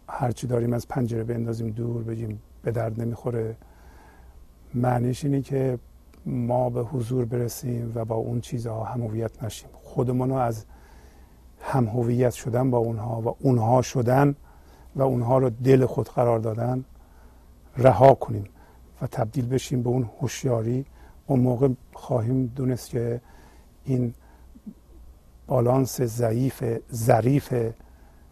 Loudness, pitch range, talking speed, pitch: -25 LUFS, 110-125 Hz, 120 wpm, 120 Hz